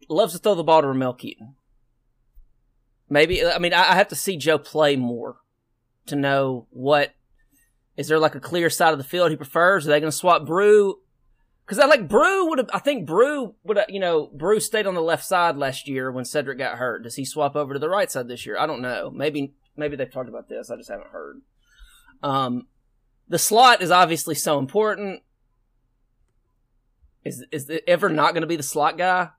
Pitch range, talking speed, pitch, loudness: 125-175 Hz, 210 wpm, 150 Hz, -21 LUFS